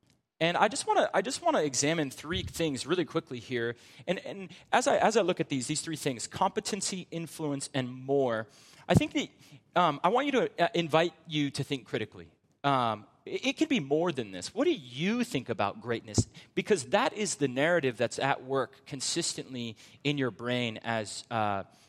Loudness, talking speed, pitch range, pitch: -30 LUFS, 195 wpm, 125-175 Hz, 145 Hz